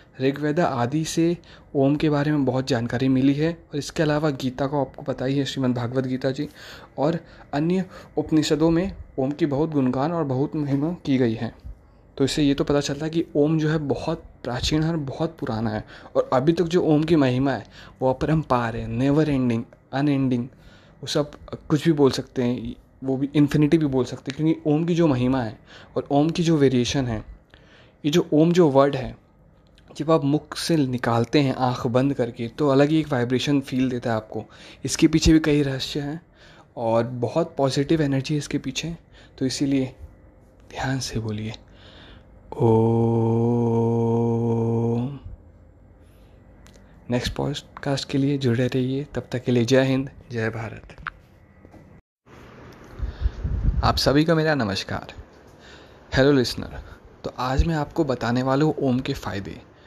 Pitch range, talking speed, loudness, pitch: 115-150 Hz, 170 wpm, -23 LUFS, 135 Hz